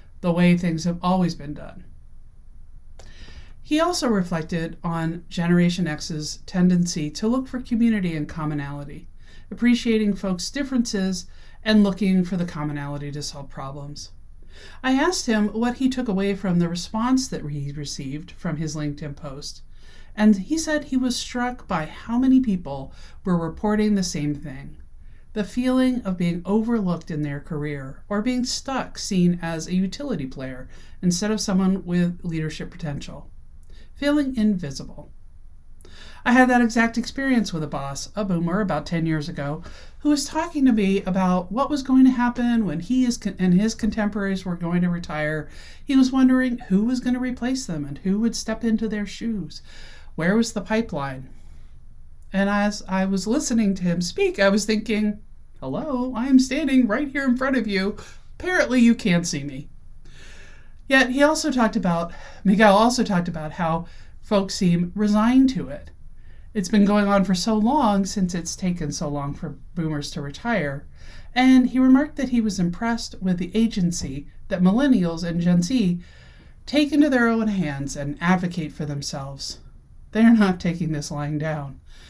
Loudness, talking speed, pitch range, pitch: -22 LUFS, 170 wpm, 155-230 Hz, 190 Hz